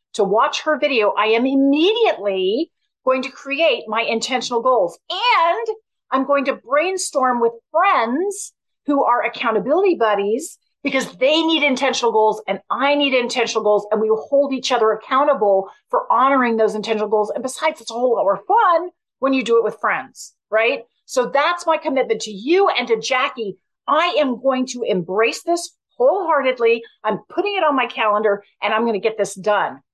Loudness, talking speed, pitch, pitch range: -18 LUFS, 180 wpm, 260 Hz, 220-305 Hz